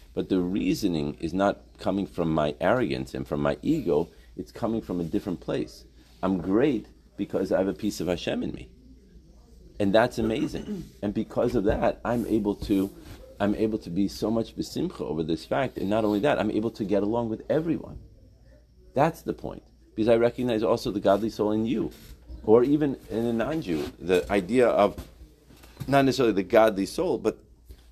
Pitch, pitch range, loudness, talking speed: 100 Hz, 80-110 Hz, -26 LUFS, 185 wpm